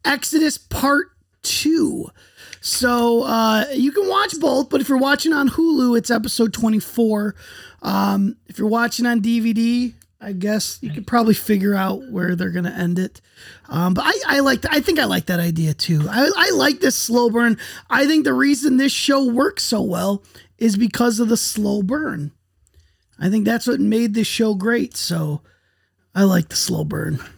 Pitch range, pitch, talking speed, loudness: 190-270 Hz, 230 Hz, 180 wpm, -18 LUFS